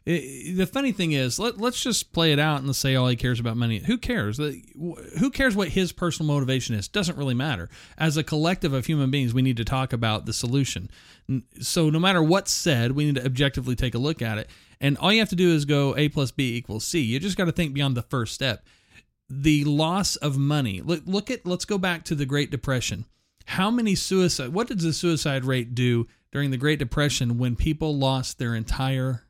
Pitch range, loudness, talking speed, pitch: 125-170 Hz, -24 LUFS, 225 wpm, 145 Hz